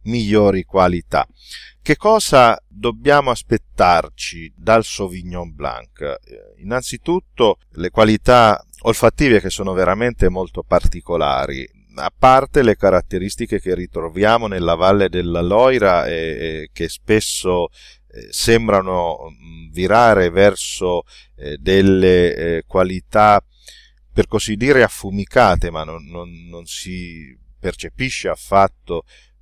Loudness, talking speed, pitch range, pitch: -16 LUFS, 105 wpm, 85-115 Hz, 95 Hz